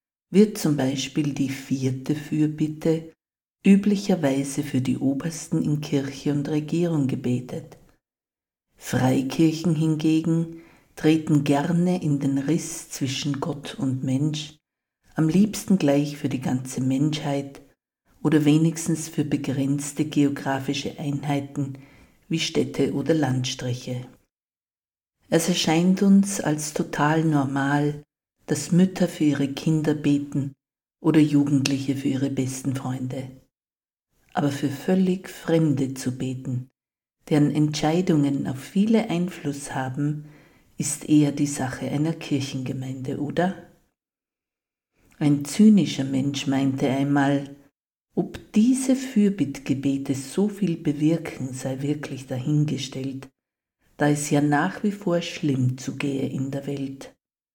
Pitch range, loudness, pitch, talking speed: 135-160 Hz, -24 LUFS, 145 Hz, 110 wpm